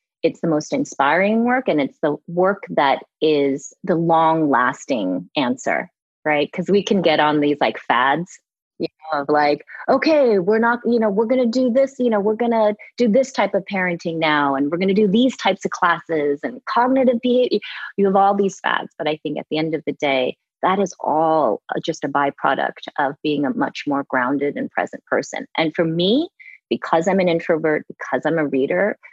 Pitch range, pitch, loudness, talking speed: 150-225 Hz, 175 Hz, -19 LUFS, 200 wpm